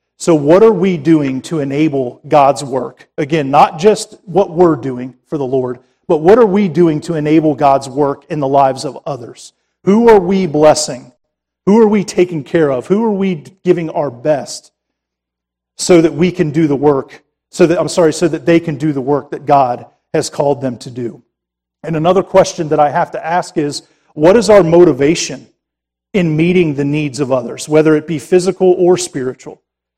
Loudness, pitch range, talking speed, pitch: -13 LUFS, 140-175 Hz, 195 wpm, 155 Hz